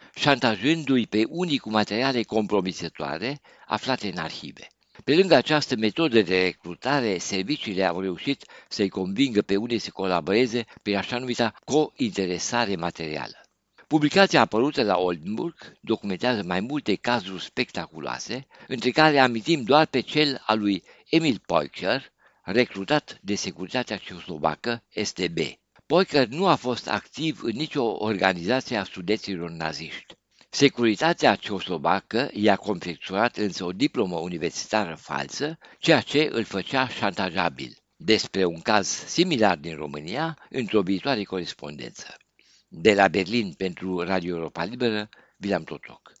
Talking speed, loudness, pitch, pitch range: 125 wpm, -25 LUFS, 110 Hz, 95-135 Hz